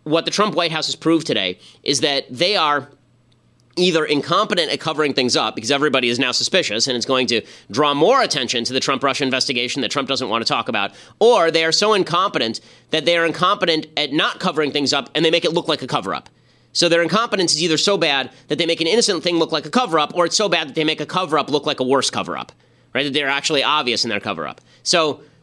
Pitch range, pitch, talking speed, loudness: 130-165 Hz, 150 Hz, 245 wpm, -18 LUFS